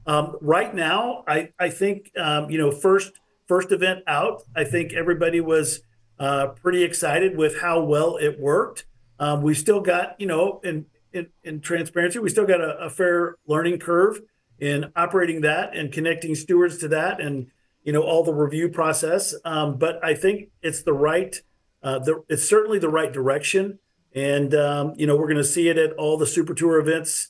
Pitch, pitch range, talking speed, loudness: 160 Hz, 150-175 Hz, 190 wpm, -22 LUFS